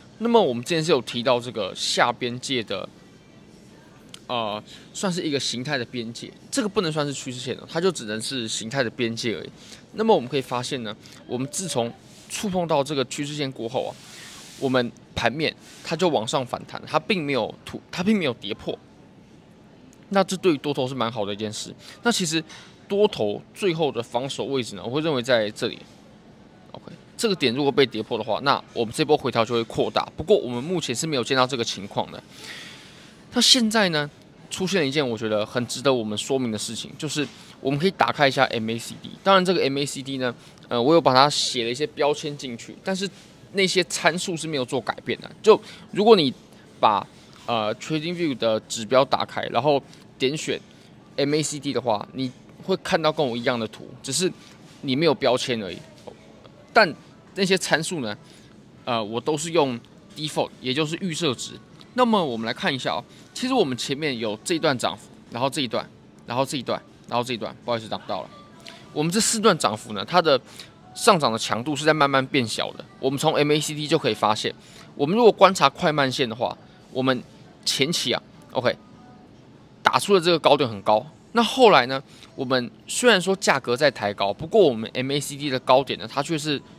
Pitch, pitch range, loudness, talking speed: 140 Hz, 120-175 Hz, -23 LUFS, 310 characters per minute